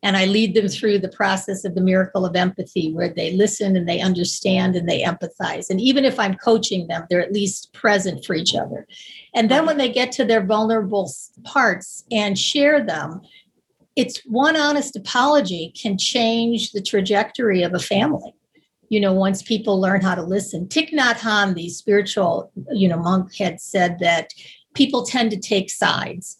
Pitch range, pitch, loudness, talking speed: 185-225 Hz, 200 Hz, -19 LUFS, 185 wpm